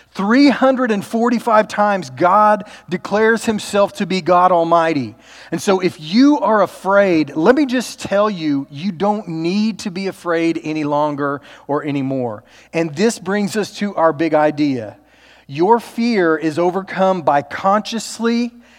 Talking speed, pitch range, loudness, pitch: 140 wpm, 160-215 Hz, -16 LUFS, 190 Hz